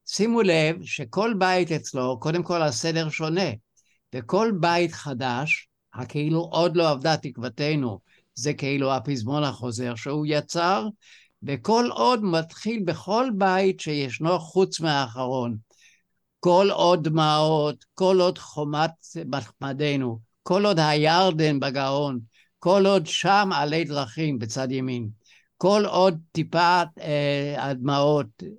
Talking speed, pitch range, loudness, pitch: 110 wpm, 140-180 Hz, -24 LUFS, 155 Hz